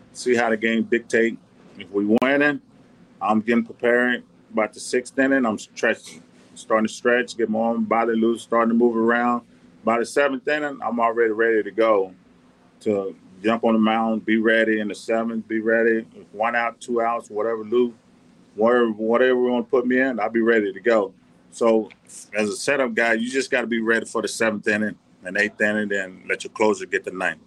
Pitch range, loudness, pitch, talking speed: 110-120 Hz, -22 LUFS, 115 Hz, 205 wpm